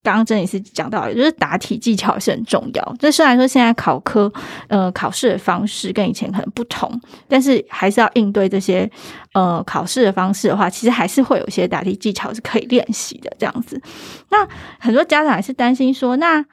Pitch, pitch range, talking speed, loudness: 225 Hz, 200-255 Hz, 325 characters per minute, -17 LUFS